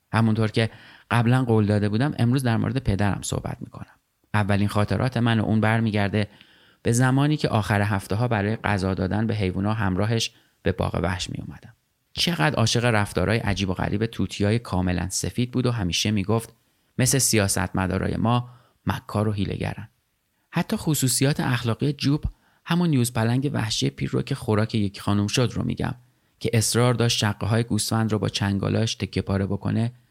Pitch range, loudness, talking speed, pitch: 100-120 Hz, -24 LUFS, 165 wpm, 110 Hz